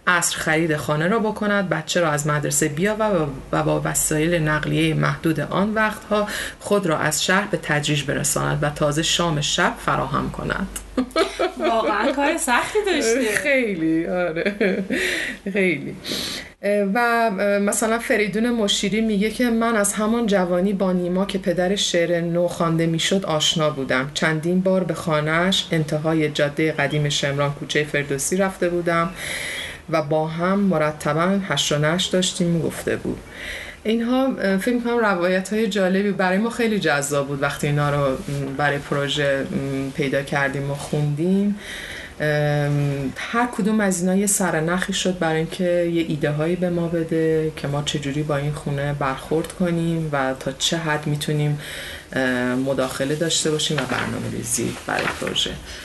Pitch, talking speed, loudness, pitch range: 165 Hz, 145 wpm, -21 LUFS, 150-195 Hz